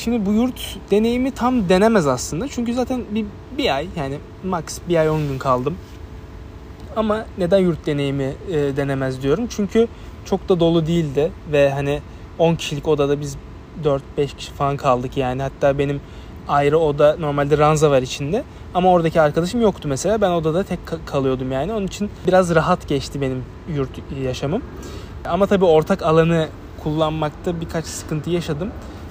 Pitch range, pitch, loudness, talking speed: 140-185 Hz, 155 Hz, -20 LUFS, 155 wpm